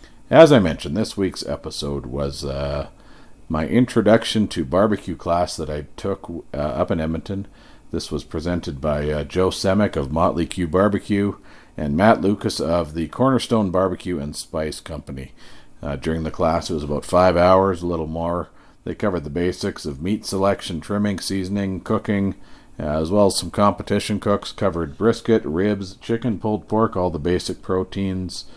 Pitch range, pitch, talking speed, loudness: 80-100 Hz, 95 Hz, 170 wpm, -21 LUFS